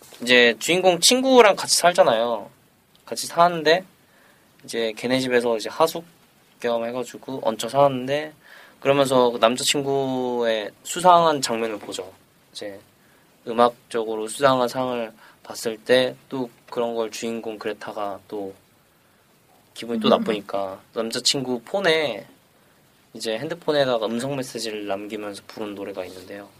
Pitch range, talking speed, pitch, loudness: 110-140 Hz, 285 characters per minute, 120 Hz, -21 LUFS